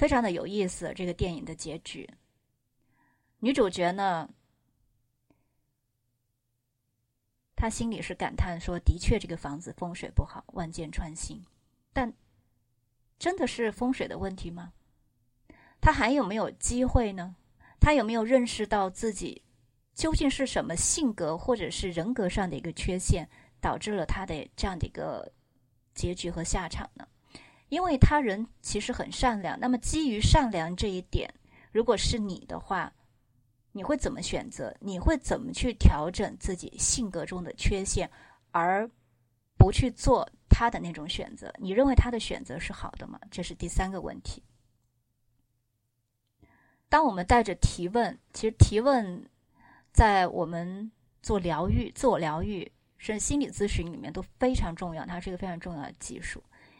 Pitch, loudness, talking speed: 180 Hz, -29 LUFS, 230 characters per minute